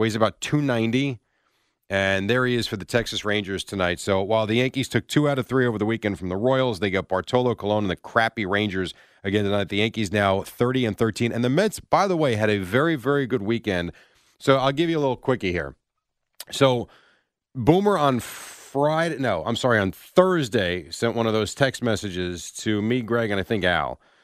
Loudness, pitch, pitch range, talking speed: -23 LUFS, 115 Hz, 100-130 Hz, 215 wpm